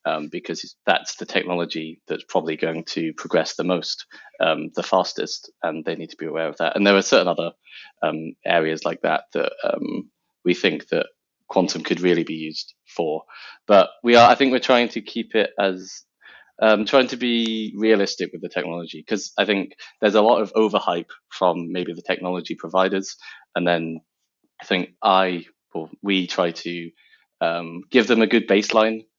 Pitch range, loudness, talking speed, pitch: 85-110 Hz, -21 LUFS, 185 wpm, 95 Hz